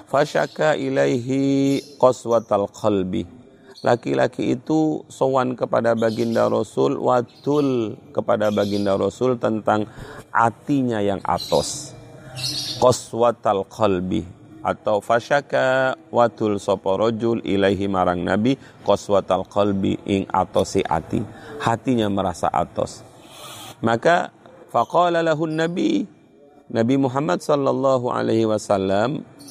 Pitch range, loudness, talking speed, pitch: 105-140 Hz, -21 LUFS, 90 wpm, 120 Hz